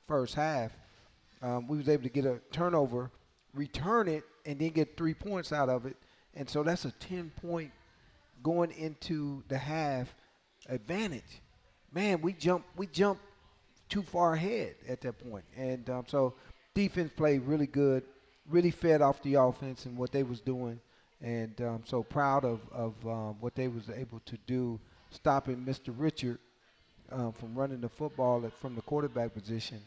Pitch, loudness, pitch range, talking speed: 135 Hz, -34 LUFS, 120-155 Hz, 170 wpm